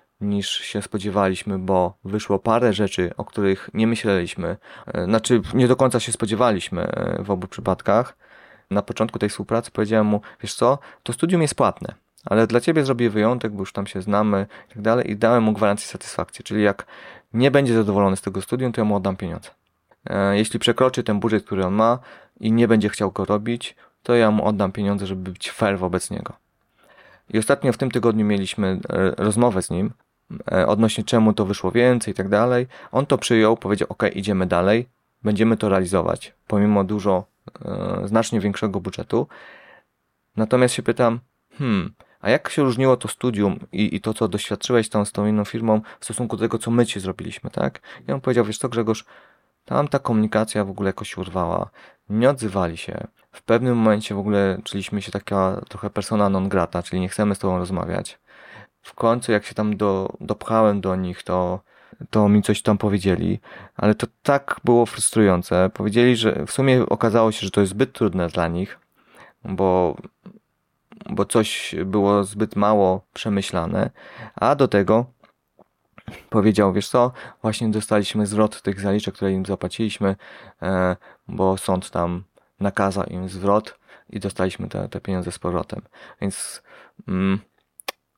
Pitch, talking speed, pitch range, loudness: 105 Hz, 170 wpm, 95-115 Hz, -21 LUFS